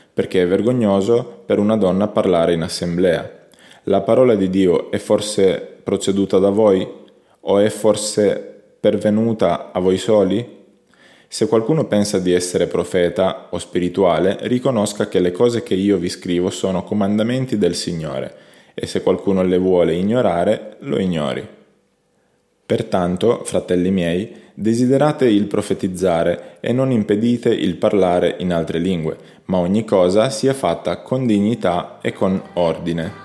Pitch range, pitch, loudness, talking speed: 90-110 Hz, 100 Hz, -18 LUFS, 140 wpm